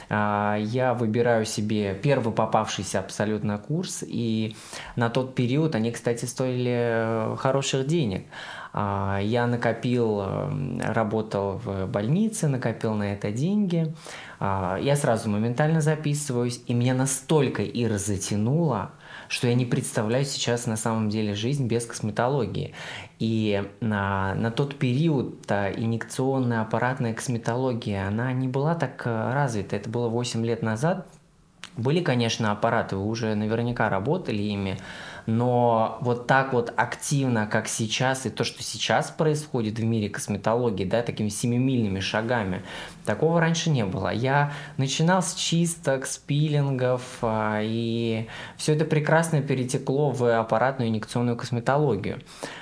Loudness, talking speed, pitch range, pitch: -25 LUFS, 125 wpm, 110-135 Hz, 120 Hz